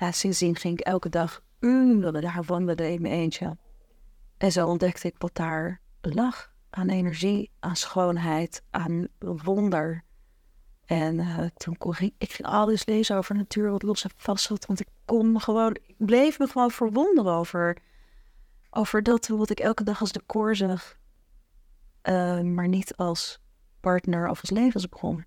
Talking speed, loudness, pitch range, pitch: 170 wpm, -26 LUFS, 170-215 Hz, 180 Hz